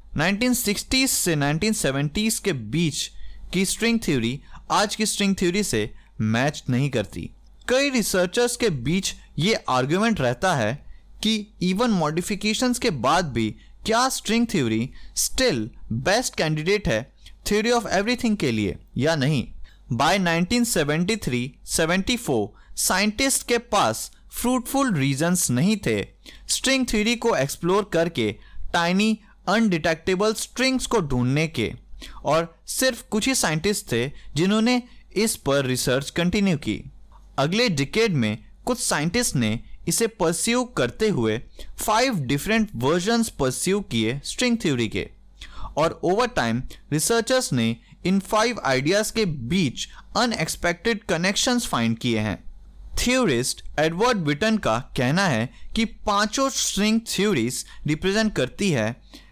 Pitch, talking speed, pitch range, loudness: 185 Hz, 125 wpm, 140-225 Hz, -23 LUFS